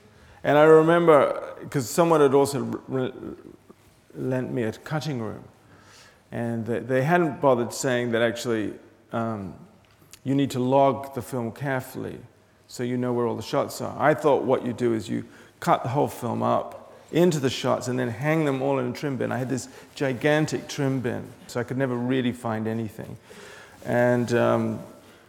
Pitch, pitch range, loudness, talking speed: 125 Hz, 115-135 Hz, -24 LUFS, 180 wpm